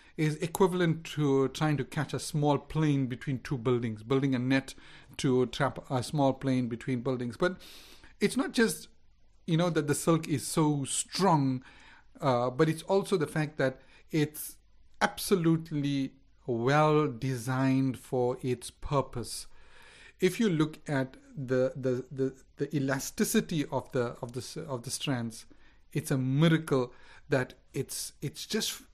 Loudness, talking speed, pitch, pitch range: -30 LUFS, 145 wpm, 135 Hz, 130-155 Hz